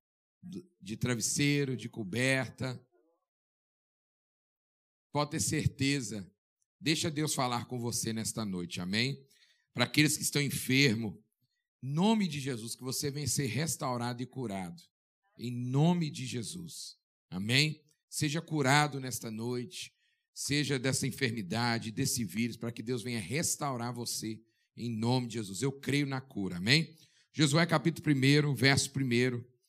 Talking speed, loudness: 130 wpm, -32 LUFS